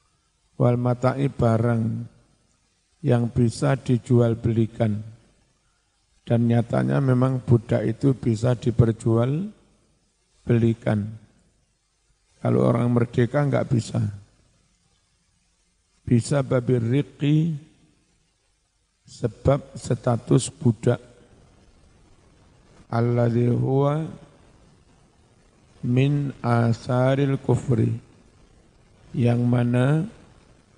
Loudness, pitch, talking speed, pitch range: -23 LUFS, 120 Hz, 65 wpm, 115-130 Hz